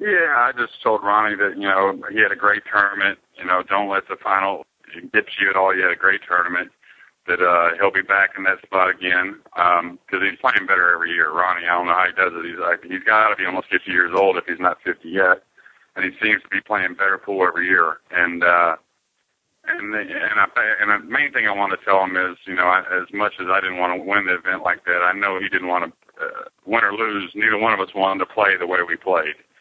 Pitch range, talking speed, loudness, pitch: 90-105 Hz, 260 wpm, -19 LUFS, 95 Hz